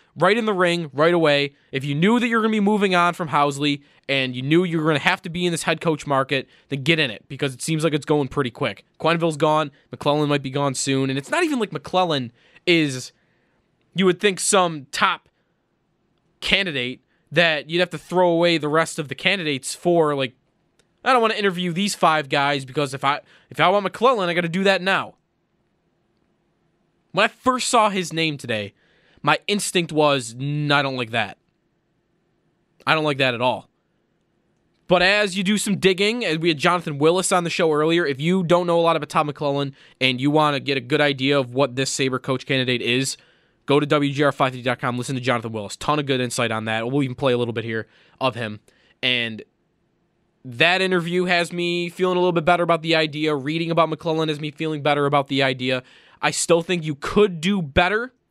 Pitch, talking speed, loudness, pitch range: 155 Hz, 215 wpm, -21 LUFS, 135-175 Hz